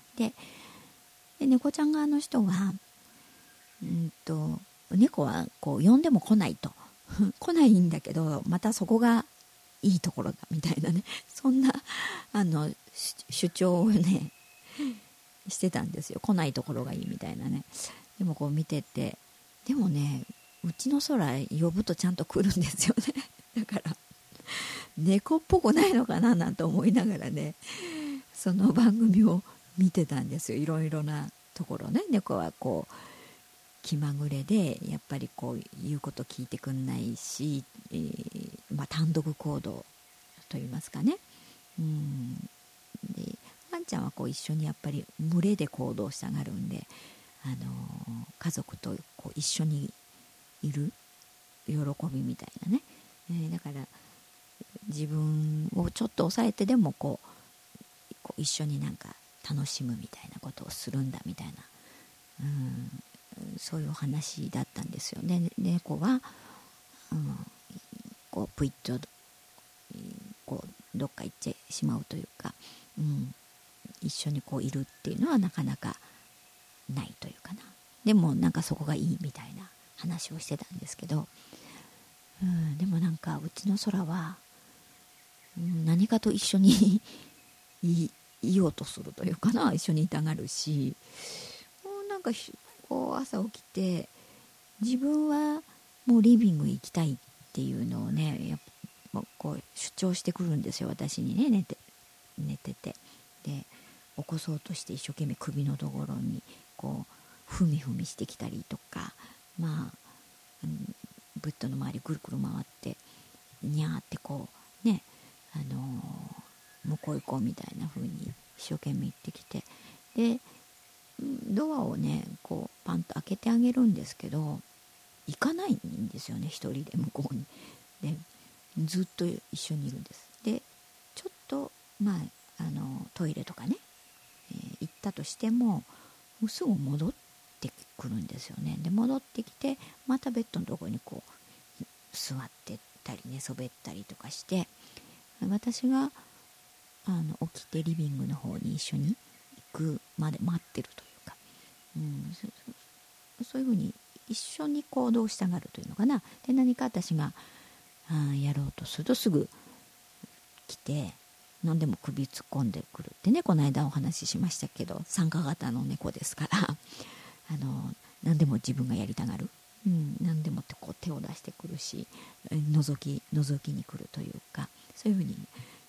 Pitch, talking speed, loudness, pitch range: 175 Hz, 275 characters per minute, -31 LUFS, 150-220 Hz